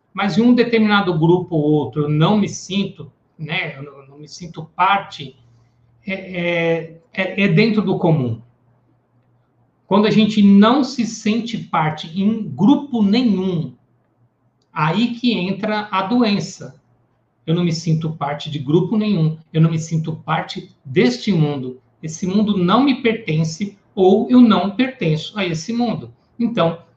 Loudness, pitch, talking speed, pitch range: -17 LUFS, 175 Hz, 150 wpm, 150-205 Hz